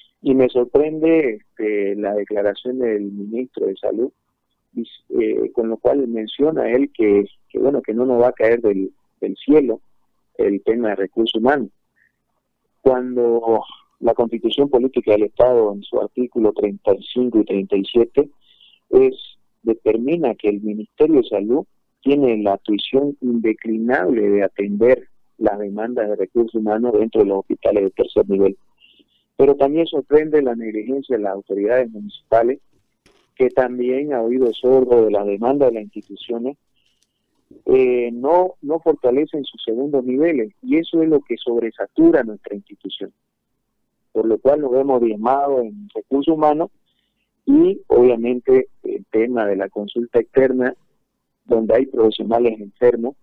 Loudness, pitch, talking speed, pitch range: -18 LUFS, 120 Hz, 140 wpm, 105-135 Hz